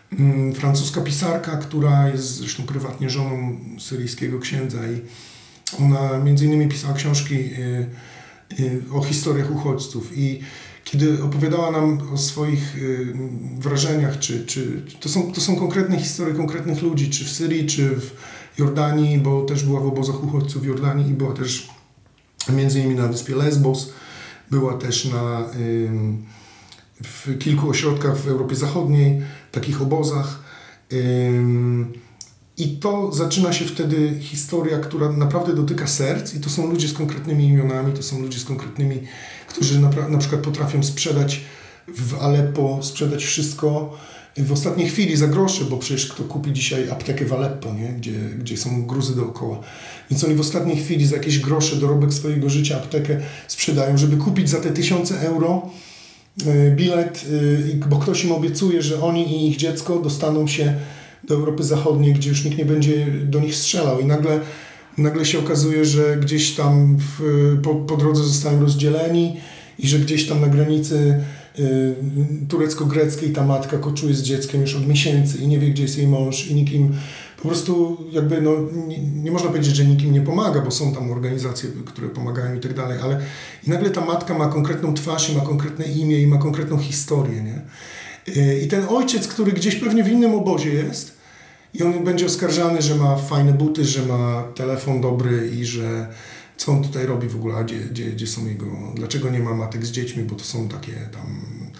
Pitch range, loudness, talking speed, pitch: 135-155 Hz, -20 LUFS, 170 wpm, 145 Hz